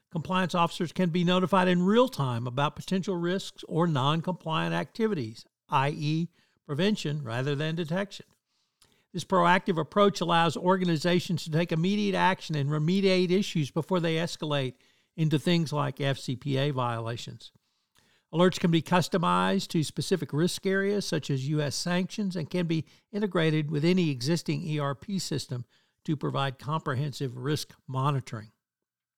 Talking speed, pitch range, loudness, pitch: 135 wpm, 145-180 Hz, -28 LUFS, 165 Hz